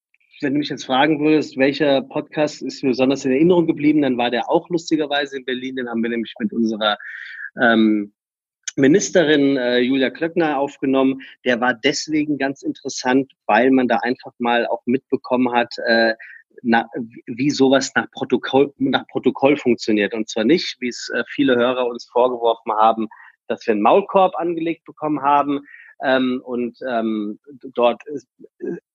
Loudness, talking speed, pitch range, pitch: -19 LUFS, 165 wpm, 120-145 Hz, 130 Hz